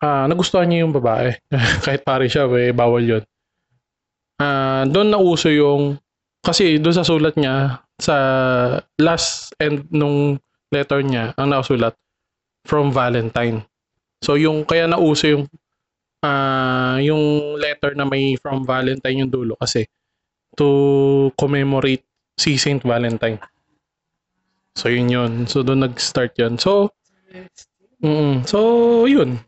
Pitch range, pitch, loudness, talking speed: 125-150 Hz, 140 Hz, -17 LUFS, 130 wpm